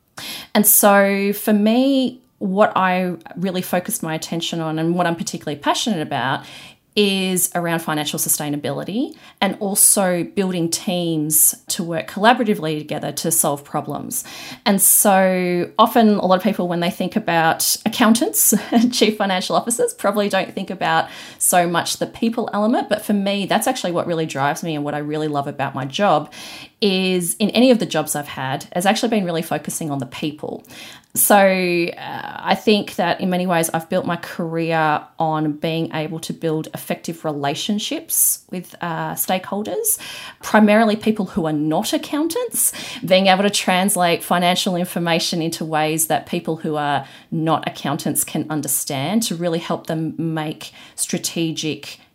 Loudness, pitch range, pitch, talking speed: -18 LUFS, 160-210 Hz, 180 Hz, 160 wpm